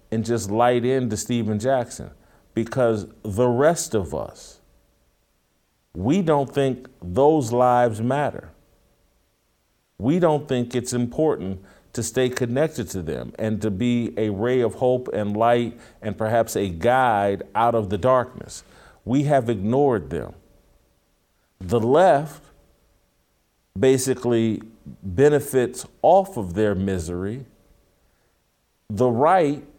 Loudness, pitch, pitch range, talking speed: -22 LUFS, 115 Hz, 100-130 Hz, 115 wpm